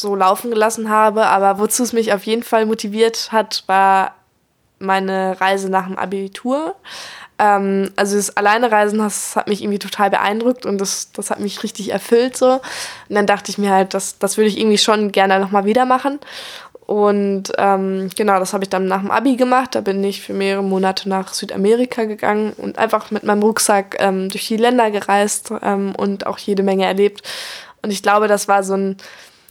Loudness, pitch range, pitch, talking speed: -17 LUFS, 195-220 Hz, 205 Hz, 195 wpm